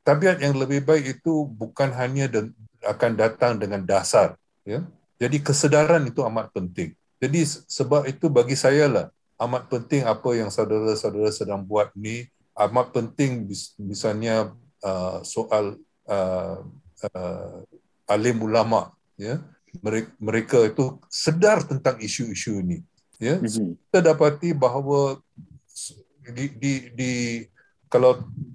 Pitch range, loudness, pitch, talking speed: 110-140 Hz, -23 LUFS, 125 Hz, 115 wpm